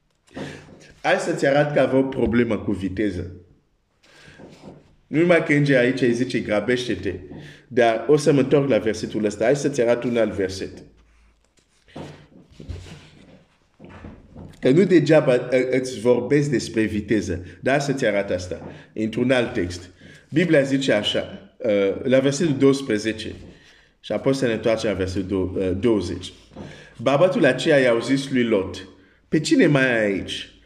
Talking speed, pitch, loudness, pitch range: 140 wpm, 115 Hz, -21 LUFS, 95-130 Hz